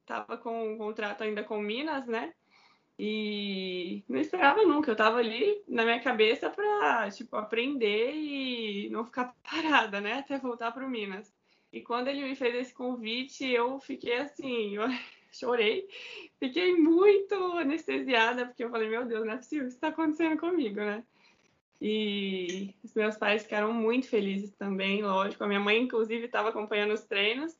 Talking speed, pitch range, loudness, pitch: 165 wpm, 215-275 Hz, -30 LUFS, 235 Hz